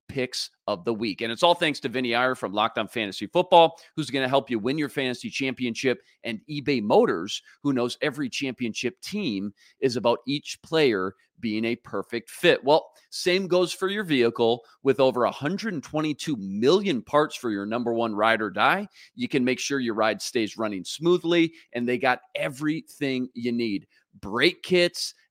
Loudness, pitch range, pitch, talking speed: -25 LUFS, 115-165 Hz, 130 Hz, 180 wpm